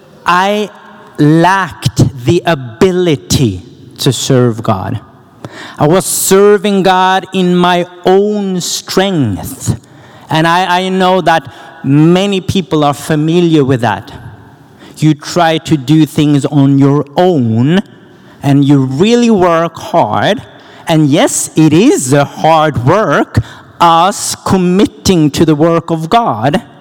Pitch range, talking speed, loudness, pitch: 135-180 Hz, 120 wpm, -10 LUFS, 160 Hz